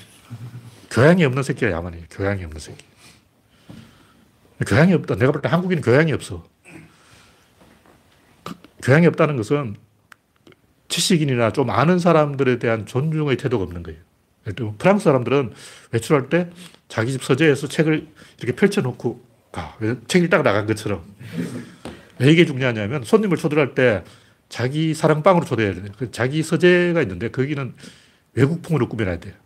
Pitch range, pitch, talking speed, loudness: 110-155 Hz, 130 Hz, 320 characters per minute, -19 LUFS